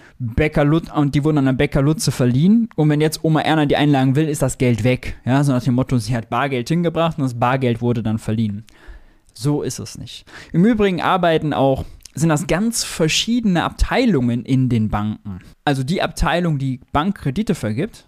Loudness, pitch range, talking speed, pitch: -18 LUFS, 120-160 Hz, 195 wpm, 140 Hz